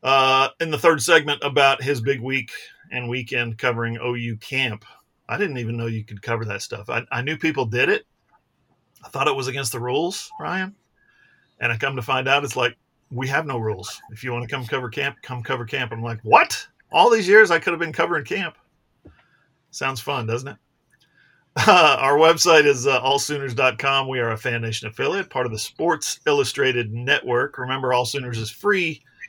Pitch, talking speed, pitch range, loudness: 130 Hz, 200 wpm, 120-145 Hz, -21 LUFS